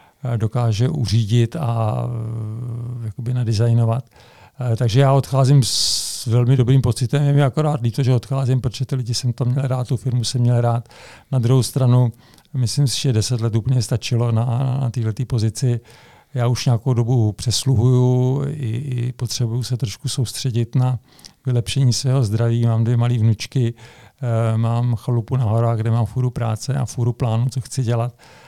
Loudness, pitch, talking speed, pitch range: -19 LUFS, 120 Hz, 160 wpm, 115-130 Hz